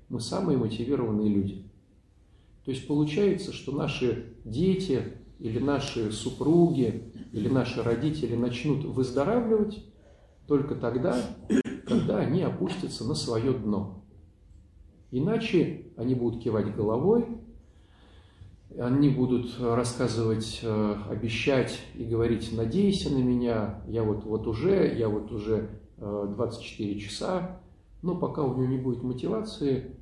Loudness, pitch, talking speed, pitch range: -28 LUFS, 120 Hz, 110 wpm, 105-140 Hz